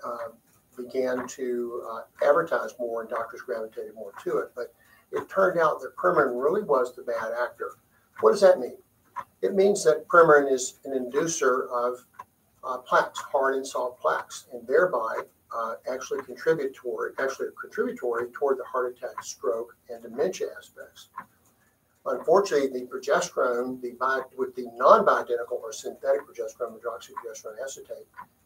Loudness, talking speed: -26 LUFS, 150 wpm